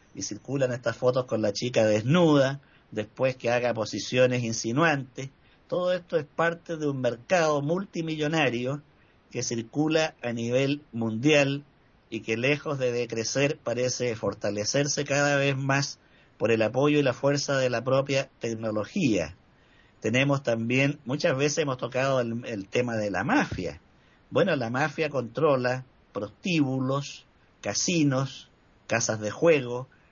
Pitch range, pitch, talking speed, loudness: 115-145 Hz, 130 Hz, 135 wpm, -26 LUFS